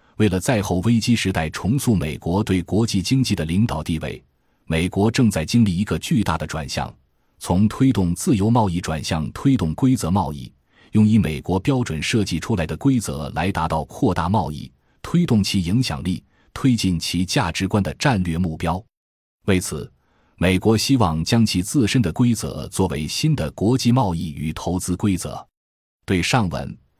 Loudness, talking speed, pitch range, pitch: -21 LUFS, 260 characters per minute, 85-115 Hz, 95 Hz